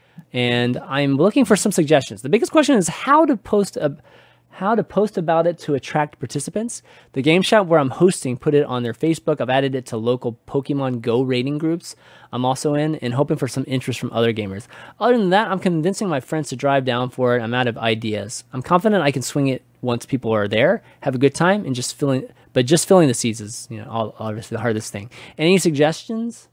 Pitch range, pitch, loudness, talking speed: 125-170 Hz, 140 Hz, -19 LUFS, 230 wpm